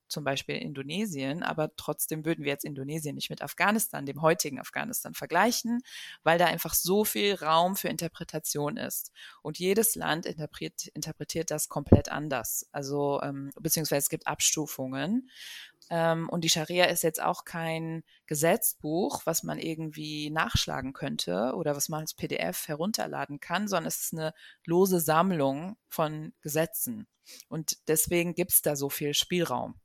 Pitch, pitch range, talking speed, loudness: 160 Hz, 150-175 Hz, 155 wpm, -29 LUFS